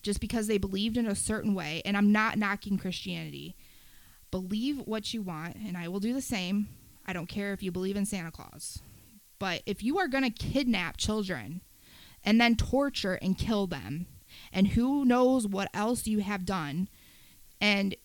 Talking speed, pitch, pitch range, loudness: 185 wpm, 200 Hz, 185-220 Hz, -30 LUFS